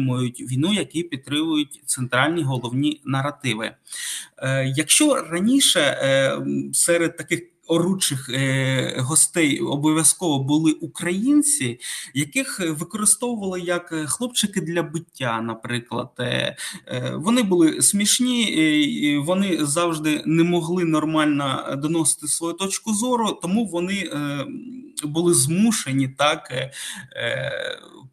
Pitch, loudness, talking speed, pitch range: 160 Hz, -21 LUFS, 105 wpm, 140-190 Hz